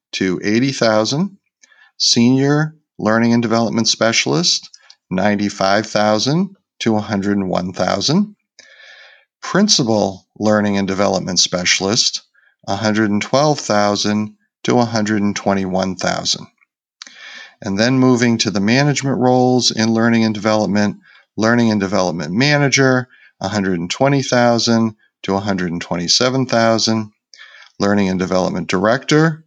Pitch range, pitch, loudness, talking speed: 100-130 Hz, 110 Hz, -16 LUFS, 80 wpm